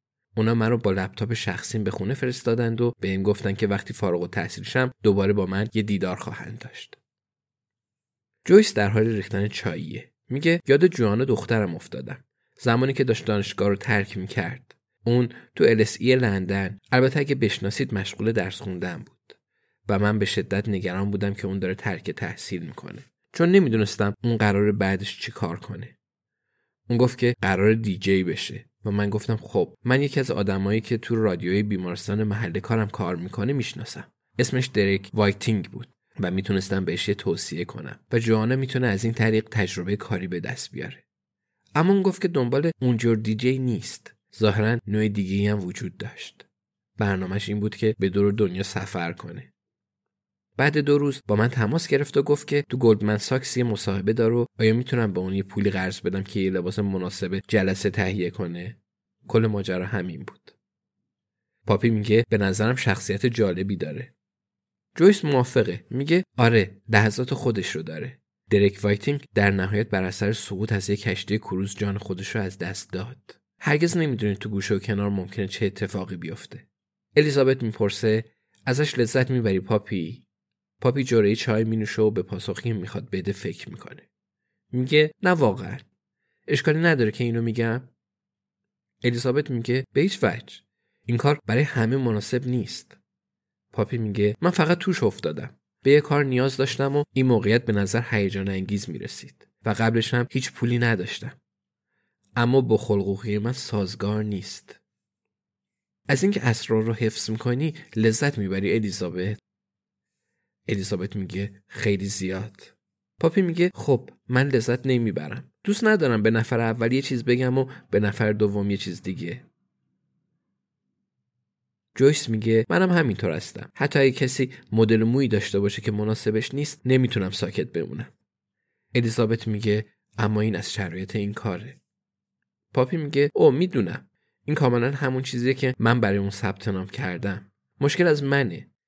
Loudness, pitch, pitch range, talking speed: -24 LUFS, 110 Hz, 100-125 Hz, 155 wpm